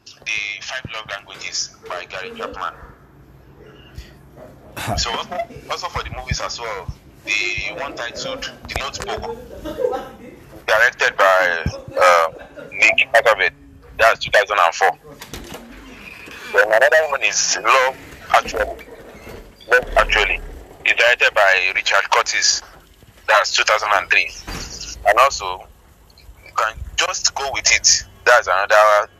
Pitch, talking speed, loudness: 90 Hz, 95 wpm, -17 LUFS